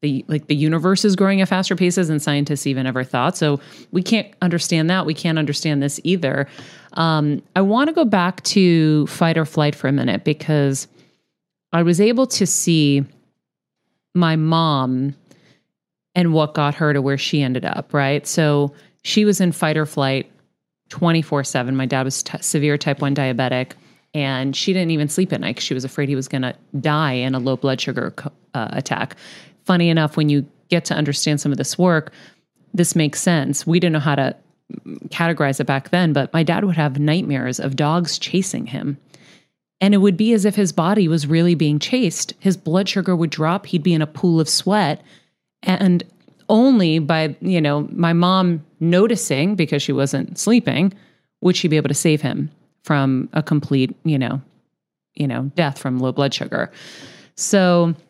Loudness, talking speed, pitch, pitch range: -18 LUFS, 190 wpm, 155 Hz, 145-180 Hz